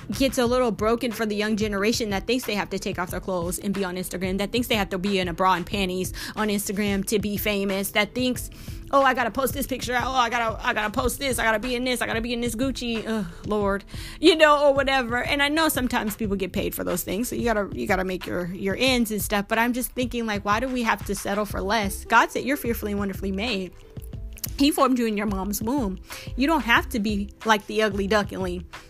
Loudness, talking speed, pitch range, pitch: -24 LUFS, 260 wpm, 200-245 Hz, 220 Hz